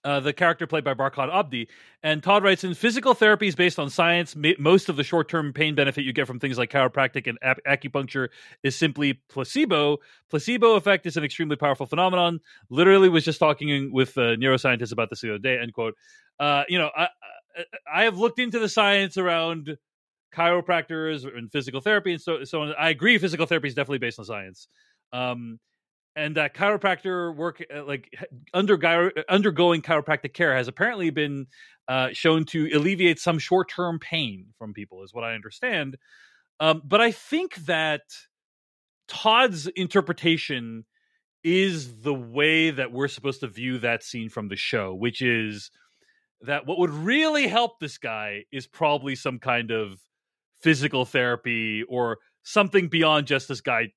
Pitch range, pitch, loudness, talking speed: 130-180 Hz, 155 Hz, -23 LUFS, 170 wpm